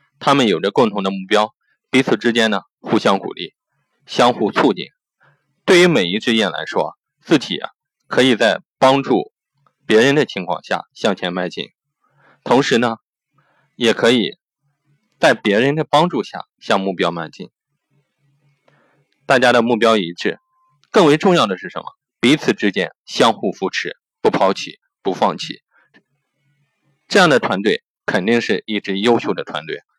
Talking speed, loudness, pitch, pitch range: 220 characters per minute, -17 LUFS, 140 Hz, 120-145 Hz